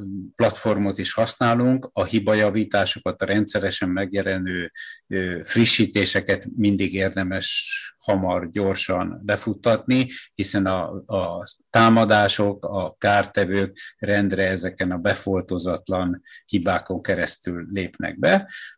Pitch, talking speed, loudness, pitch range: 100 Hz, 95 wpm, -22 LUFS, 95-110 Hz